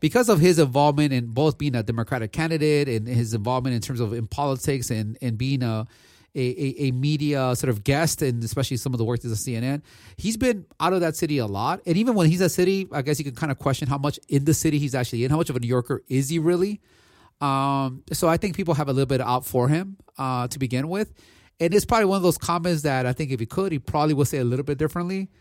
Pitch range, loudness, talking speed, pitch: 125-165 Hz, -23 LUFS, 265 wpm, 140 Hz